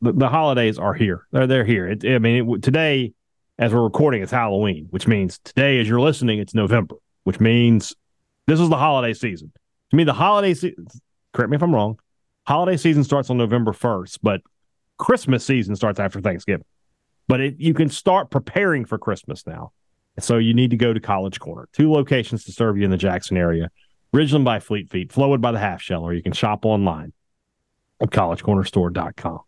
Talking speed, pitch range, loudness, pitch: 200 wpm, 100-140 Hz, -20 LUFS, 120 Hz